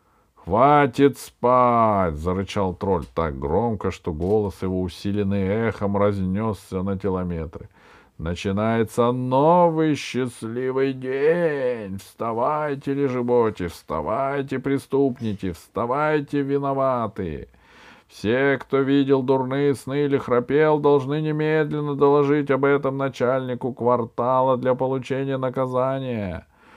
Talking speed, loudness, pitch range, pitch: 90 wpm, -22 LUFS, 100-140 Hz, 130 Hz